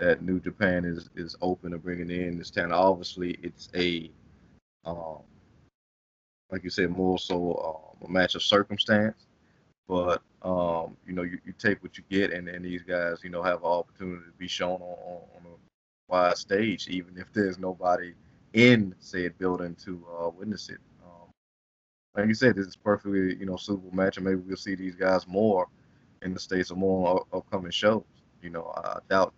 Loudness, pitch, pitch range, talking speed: -28 LUFS, 90 Hz, 85-95 Hz, 190 wpm